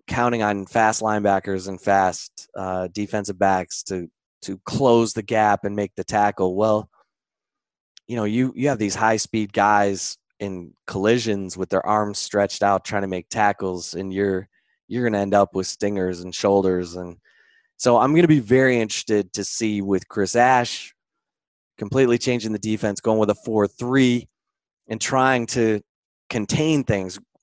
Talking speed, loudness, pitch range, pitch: 165 wpm, -21 LUFS, 95-115 Hz, 105 Hz